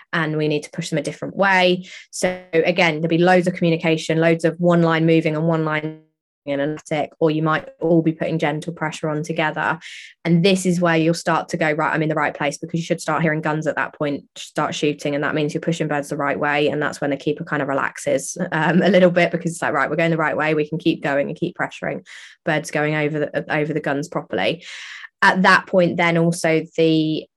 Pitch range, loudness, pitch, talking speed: 150-170 Hz, -20 LUFS, 160 Hz, 250 wpm